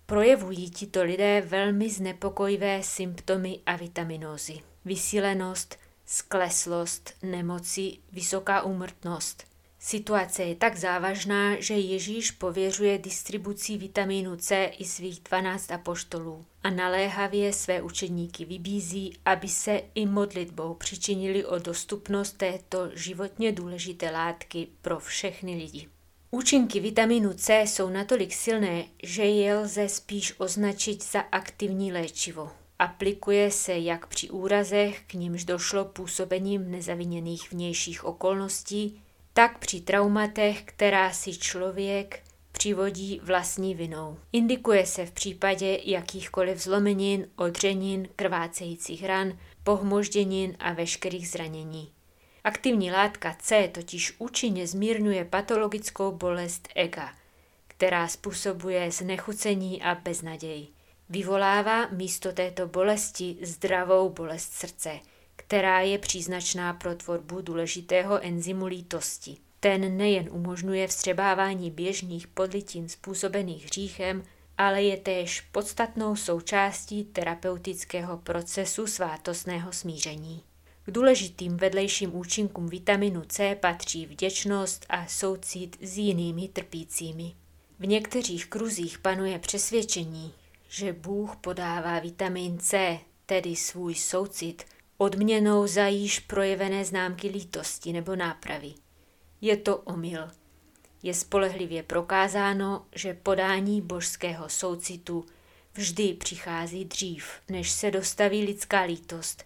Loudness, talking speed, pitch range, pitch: -28 LUFS, 105 wpm, 175-200 Hz, 190 Hz